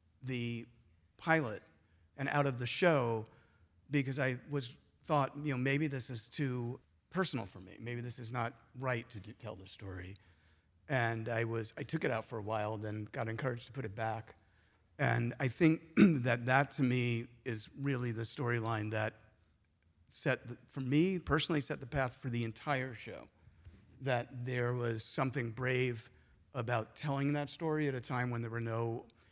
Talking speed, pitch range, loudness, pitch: 175 wpm, 110-135 Hz, -36 LUFS, 120 Hz